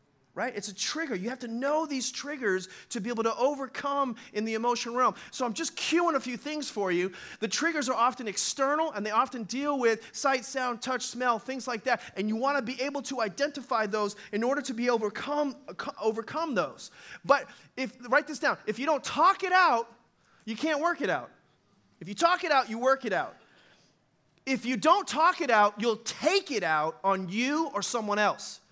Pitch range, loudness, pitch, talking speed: 225-285 Hz, -29 LUFS, 250 Hz, 210 wpm